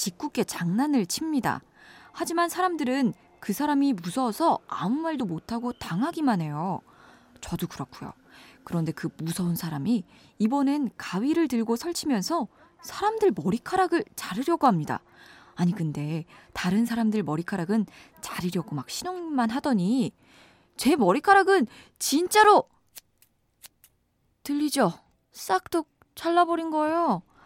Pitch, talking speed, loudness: 245 Hz, 275 characters per minute, -26 LUFS